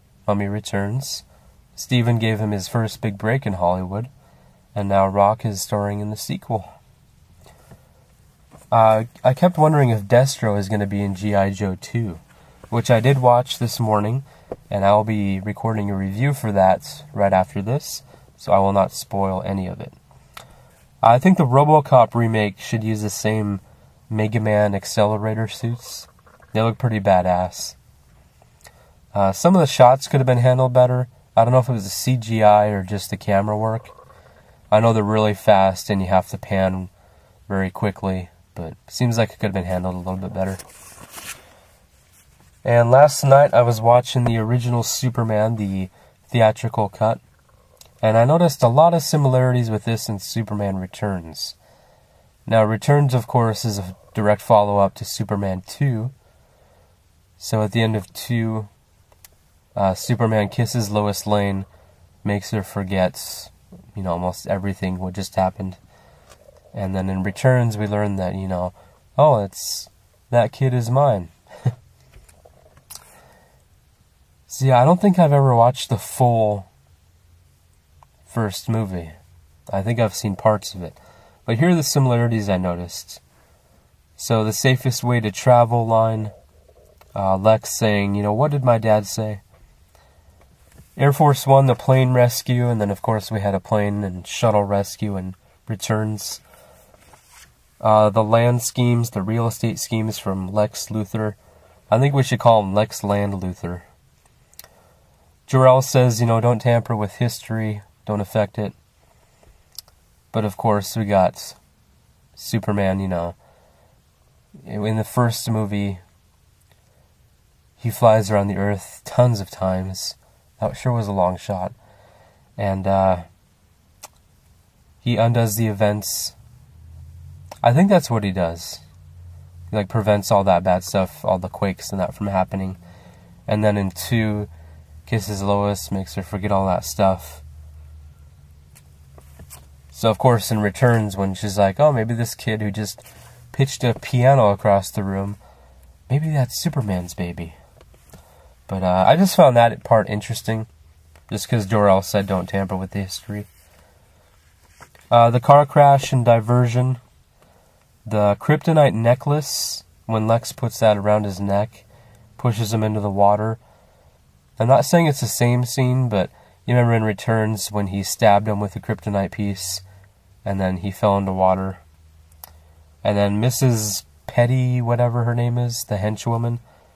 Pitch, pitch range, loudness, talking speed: 105 Hz, 95-120 Hz, -19 LUFS, 150 wpm